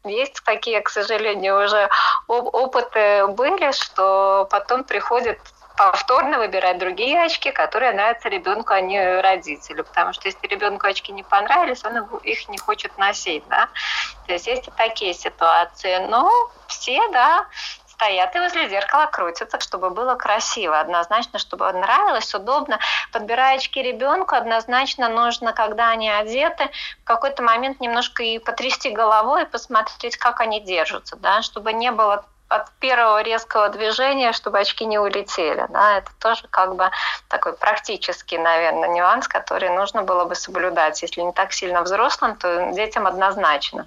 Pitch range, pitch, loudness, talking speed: 195-260 Hz, 225 Hz, -19 LUFS, 145 wpm